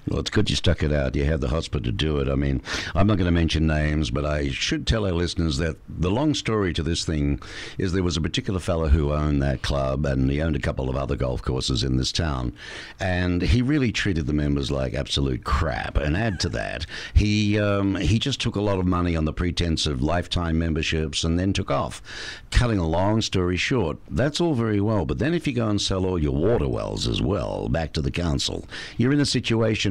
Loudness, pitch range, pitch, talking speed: -24 LUFS, 75-100 Hz, 85 Hz, 240 wpm